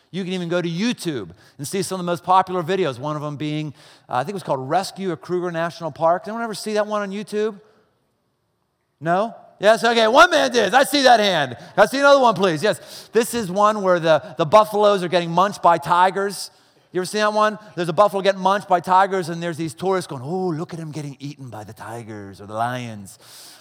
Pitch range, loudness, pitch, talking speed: 160-210 Hz, -19 LUFS, 185 Hz, 240 wpm